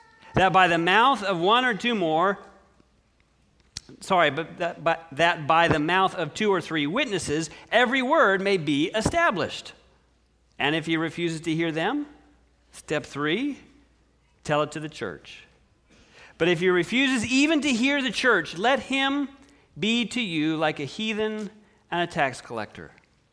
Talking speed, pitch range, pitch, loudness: 160 wpm, 160-240 Hz, 185 Hz, -24 LUFS